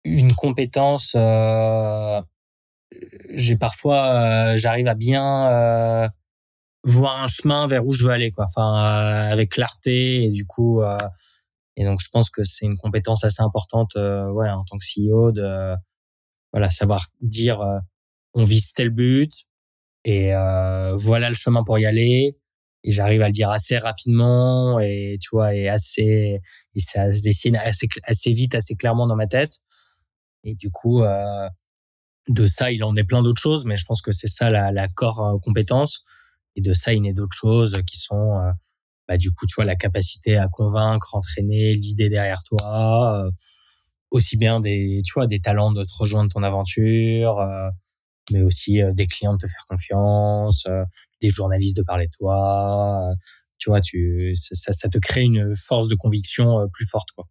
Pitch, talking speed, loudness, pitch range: 105 Hz, 185 wpm, -20 LUFS, 100-115 Hz